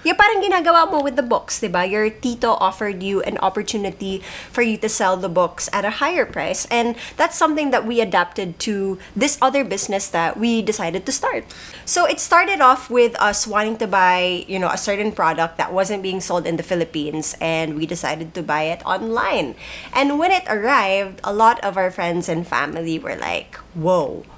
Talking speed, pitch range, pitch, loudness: 195 wpm, 180-245 Hz, 200 Hz, -19 LUFS